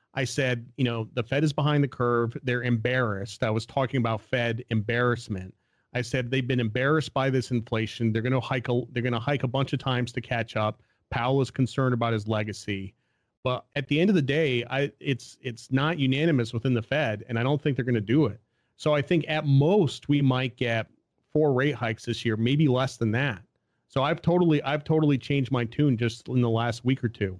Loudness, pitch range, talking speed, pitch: -26 LUFS, 115-140 Hz, 215 wpm, 125 Hz